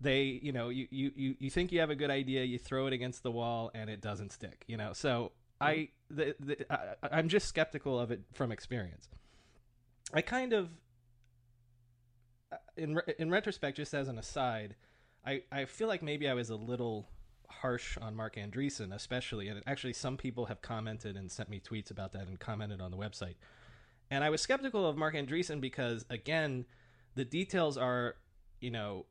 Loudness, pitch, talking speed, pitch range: -37 LUFS, 125 Hz, 190 wpm, 110-145 Hz